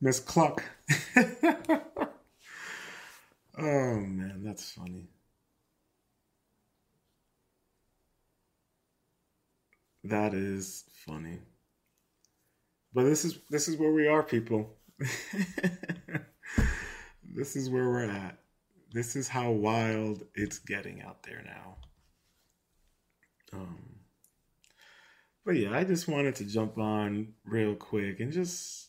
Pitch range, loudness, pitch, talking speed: 100-155 Hz, -31 LUFS, 115 Hz, 95 wpm